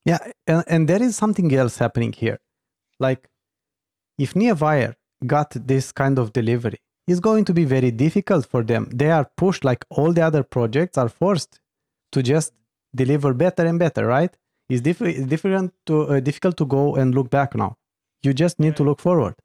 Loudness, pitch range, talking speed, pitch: -20 LUFS, 125-170 Hz, 185 wpm, 145 Hz